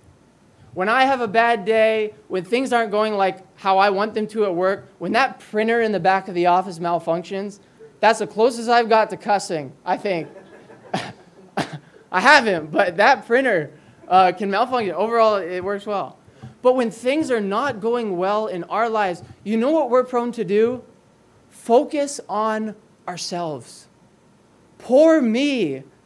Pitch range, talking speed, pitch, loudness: 190-235 Hz, 165 wpm, 215 Hz, -20 LUFS